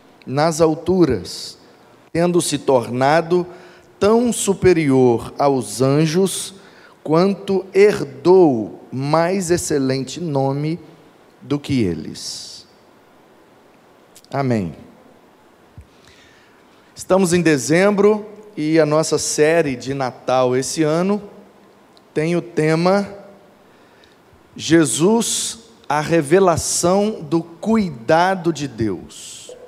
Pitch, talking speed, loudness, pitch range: 165 Hz, 80 wpm, -18 LUFS, 145-190 Hz